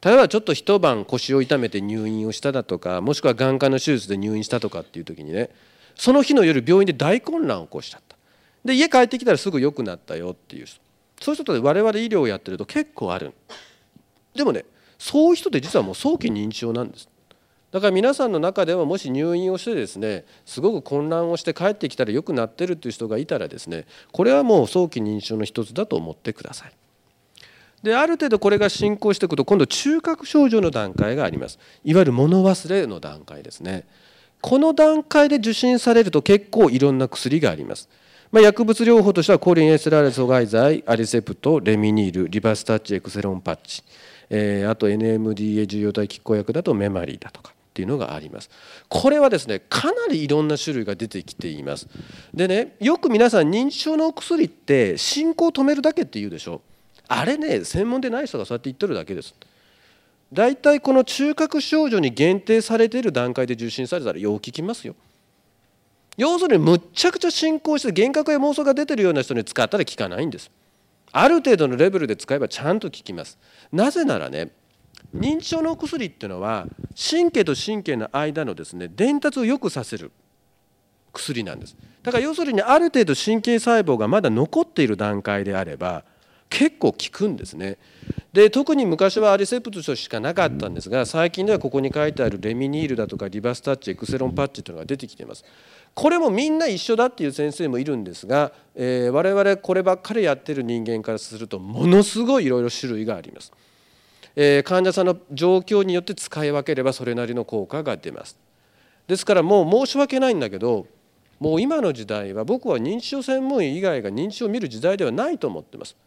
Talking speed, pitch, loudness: 415 characters per minute, 170 Hz, -20 LUFS